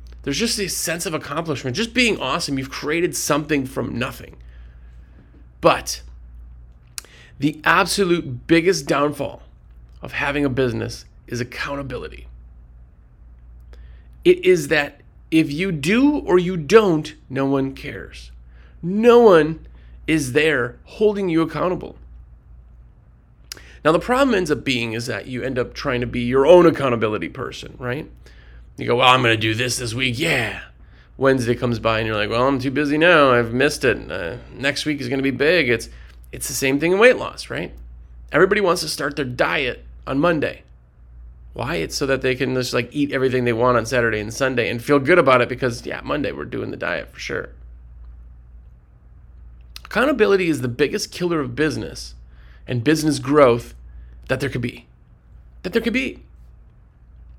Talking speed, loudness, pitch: 170 wpm, -19 LUFS, 125 Hz